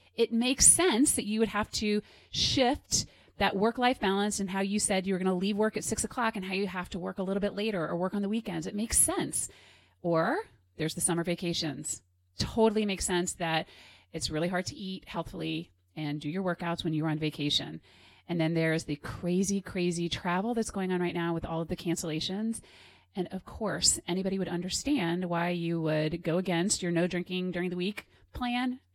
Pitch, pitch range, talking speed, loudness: 180 Hz, 165-205 Hz, 210 wpm, -30 LUFS